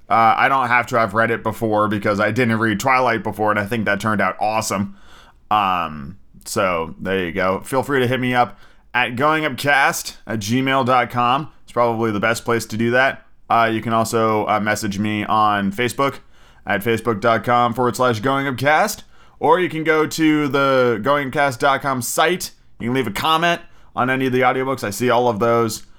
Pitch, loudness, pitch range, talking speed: 120 Hz, -18 LUFS, 110-135 Hz, 190 wpm